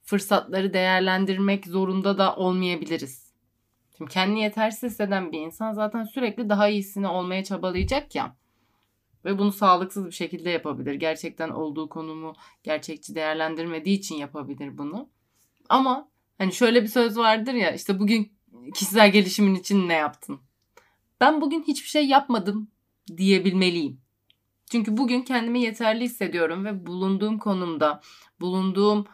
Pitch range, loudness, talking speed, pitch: 160-215 Hz, -24 LUFS, 125 wpm, 190 Hz